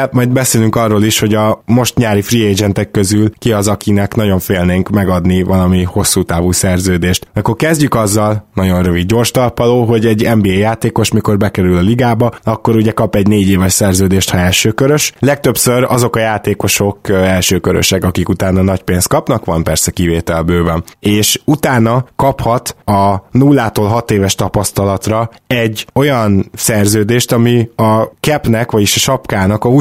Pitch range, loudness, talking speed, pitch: 95-120 Hz, -12 LUFS, 155 wpm, 105 Hz